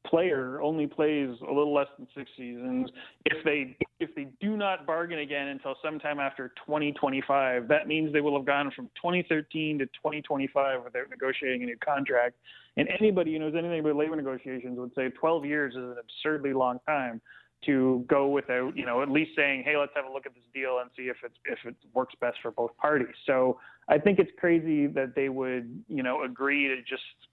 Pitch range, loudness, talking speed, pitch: 130-155 Hz, -29 LUFS, 215 wpm, 140 Hz